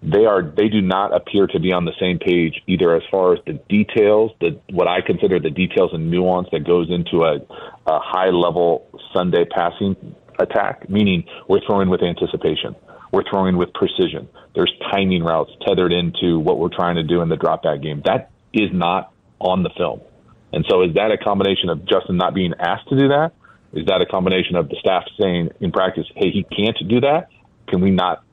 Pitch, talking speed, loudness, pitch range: 90 Hz, 205 wpm, -18 LUFS, 85-100 Hz